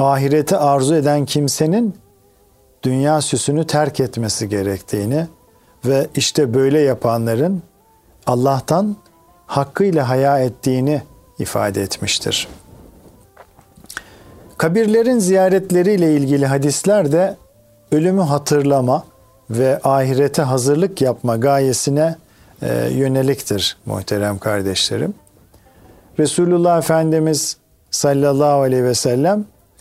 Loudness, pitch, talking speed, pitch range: -17 LUFS, 140 Hz, 80 wpm, 115-155 Hz